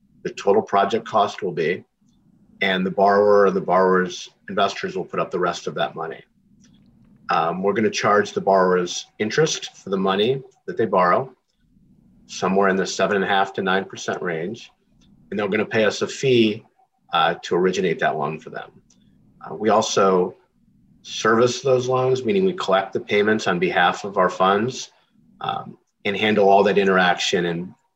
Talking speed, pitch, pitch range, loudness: 180 wpm, 105 Hz, 95-130 Hz, -20 LUFS